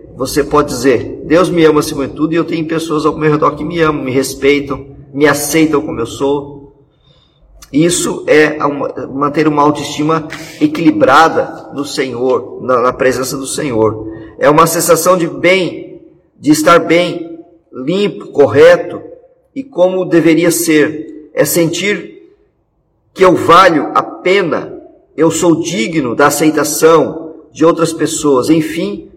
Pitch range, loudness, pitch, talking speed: 145-170 Hz, -11 LUFS, 155 Hz, 140 wpm